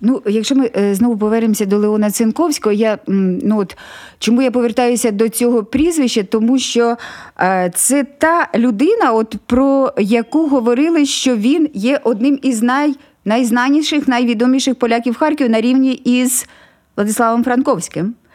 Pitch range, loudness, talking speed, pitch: 225-270 Hz, -14 LUFS, 135 wpm, 245 Hz